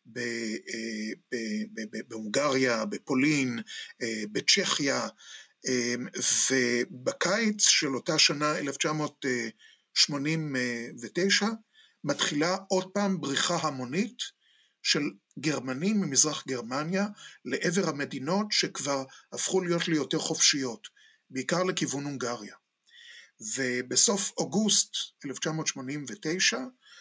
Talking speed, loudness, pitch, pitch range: 65 wpm, -28 LUFS, 150 Hz, 125-185 Hz